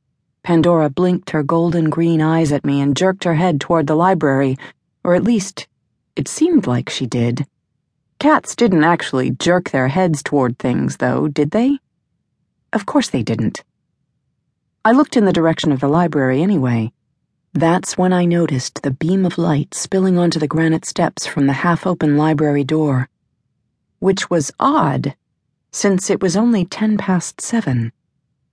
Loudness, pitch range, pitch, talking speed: -16 LUFS, 140-180 Hz, 155 Hz, 160 wpm